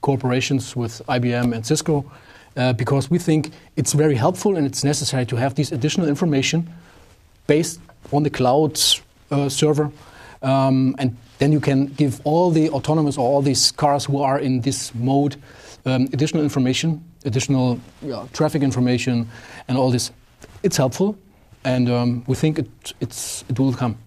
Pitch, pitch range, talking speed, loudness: 135 Hz, 125-150 Hz, 160 wpm, -20 LUFS